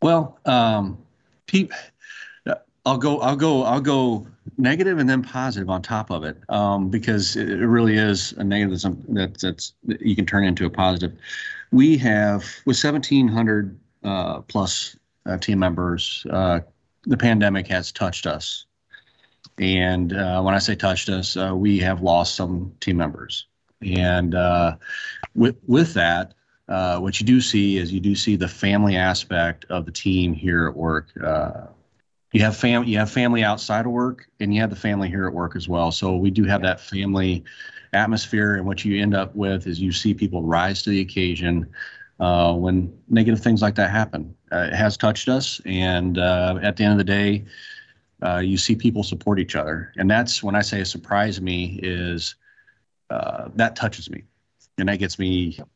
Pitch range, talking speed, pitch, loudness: 90-110 Hz, 180 wpm, 100 Hz, -21 LUFS